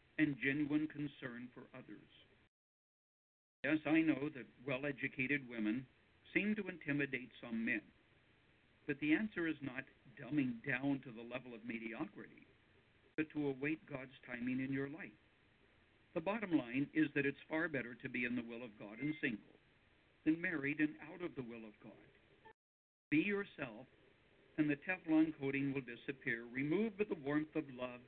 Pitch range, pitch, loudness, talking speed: 125-155 Hz, 140 Hz, -41 LUFS, 165 wpm